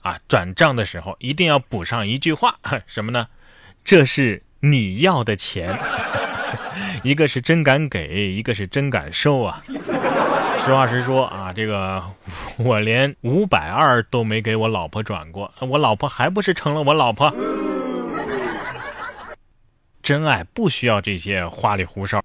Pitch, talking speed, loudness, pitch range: 120 Hz, 210 characters per minute, -20 LUFS, 100-140 Hz